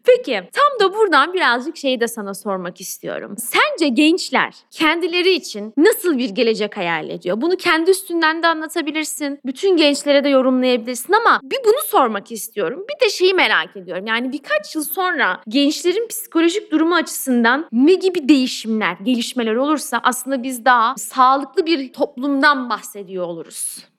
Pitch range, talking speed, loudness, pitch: 235-335 Hz, 150 wpm, -17 LUFS, 285 Hz